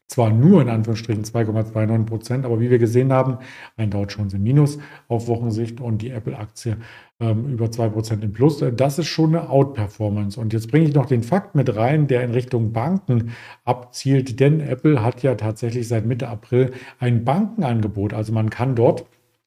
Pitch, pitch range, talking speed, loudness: 120 Hz, 110-135 Hz, 185 wpm, -20 LUFS